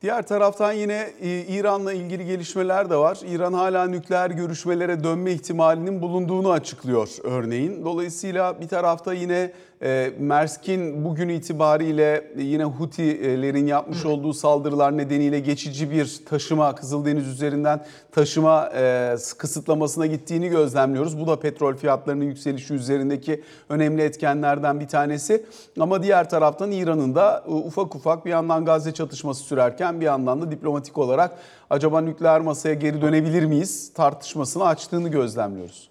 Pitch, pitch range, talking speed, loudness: 155 Hz, 145-175 Hz, 125 wpm, -22 LUFS